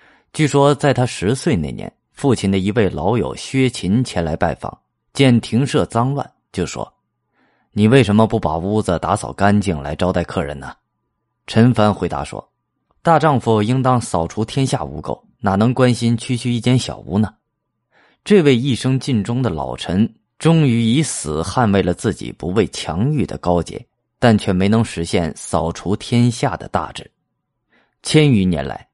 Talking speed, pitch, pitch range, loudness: 240 characters per minute, 110 Hz, 90-125 Hz, -17 LUFS